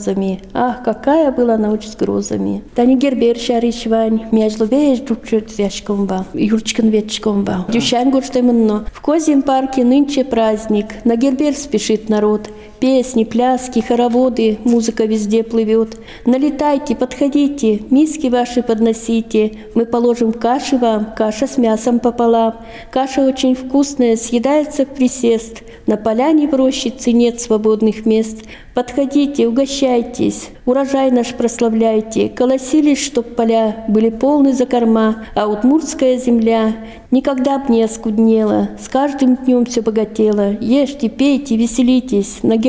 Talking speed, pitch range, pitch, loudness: 100 wpm, 220-260 Hz, 235 Hz, -15 LUFS